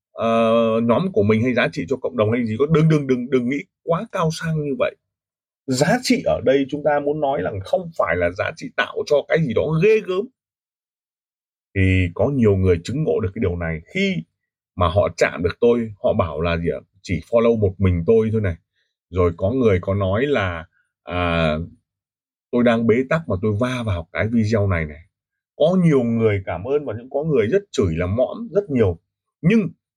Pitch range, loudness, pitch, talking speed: 95-150 Hz, -20 LUFS, 115 Hz, 215 wpm